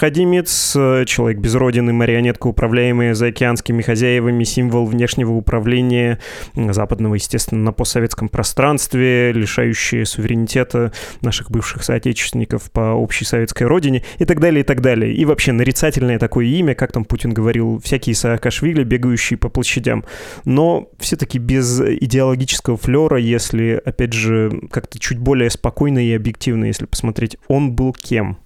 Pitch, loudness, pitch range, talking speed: 120 Hz, -16 LUFS, 115-130 Hz, 135 wpm